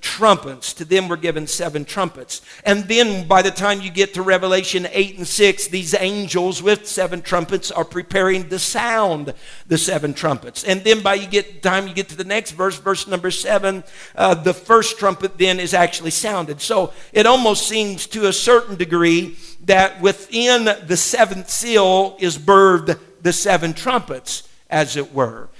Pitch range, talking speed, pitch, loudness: 175-200 Hz, 175 wpm, 190 Hz, -17 LUFS